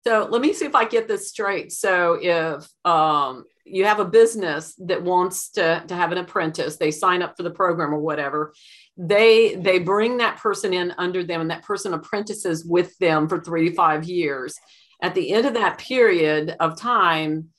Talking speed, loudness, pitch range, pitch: 200 wpm, -21 LUFS, 165-210 Hz, 180 Hz